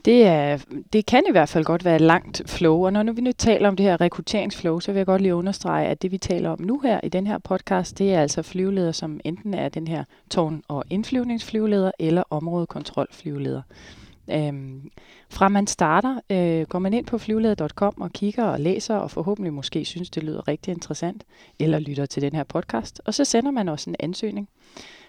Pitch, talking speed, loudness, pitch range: 180 Hz, 205 wpm, -23 LUFS, 160-205 Hz